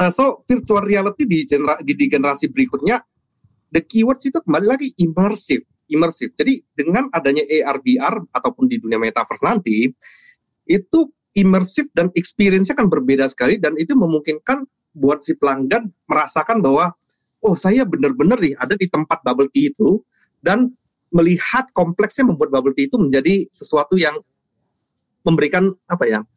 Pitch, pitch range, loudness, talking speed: 185 Hz, 150-245 Hz, -17 LUFS, 145 wpm